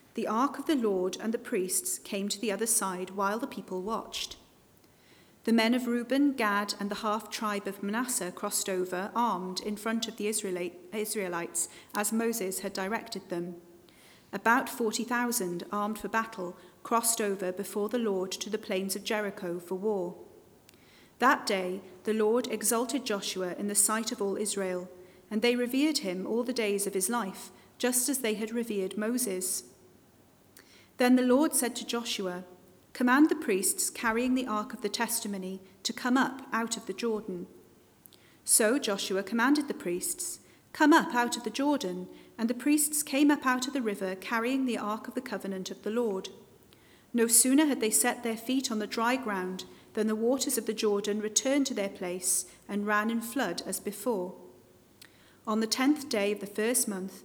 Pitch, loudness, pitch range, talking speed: 215 Hz, -30 LUFS, 195-240 Hz, 180 wpm